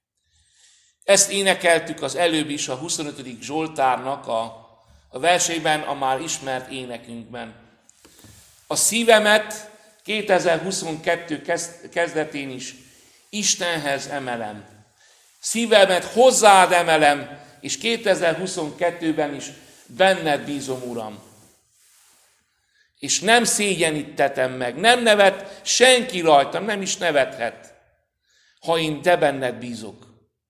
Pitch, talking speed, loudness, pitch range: 160 Hz, 90 wpm, -20 LUFS, 135-190 Hz